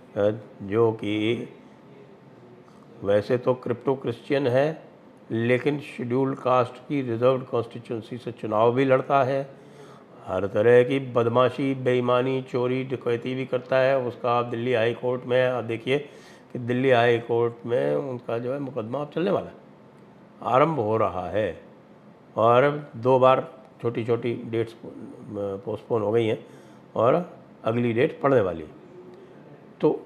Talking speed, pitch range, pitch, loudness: 135 wpm, 115-130 Hz, 125 Hz, -24 LUFS